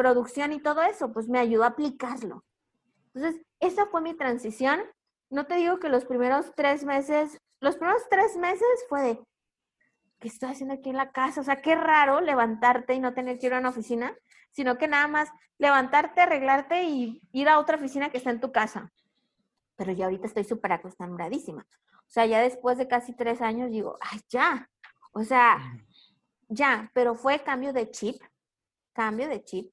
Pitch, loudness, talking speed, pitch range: 260 Hz, -26 LUFS, 185 wpm, 235-295 Hz